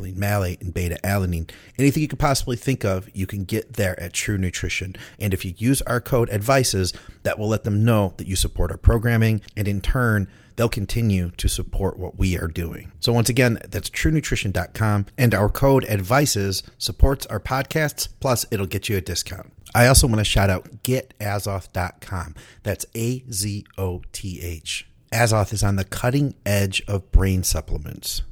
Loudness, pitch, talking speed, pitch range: -22 LUFS, 105 Hz, 180 wpm, 95-120 Hz